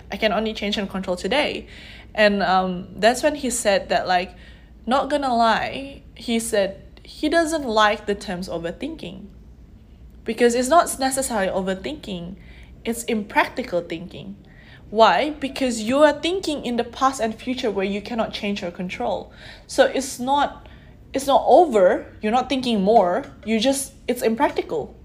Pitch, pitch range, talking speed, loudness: 225 Hz, 200-270 Hz, 155 wpm, -21 LUFS